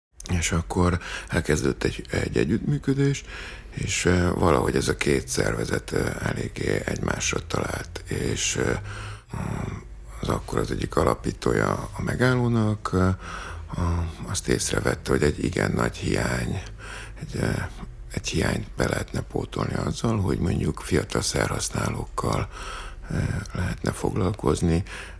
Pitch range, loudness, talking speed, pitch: 80-105 Hz, -26 LUFS, 100 wpm, 90 Hz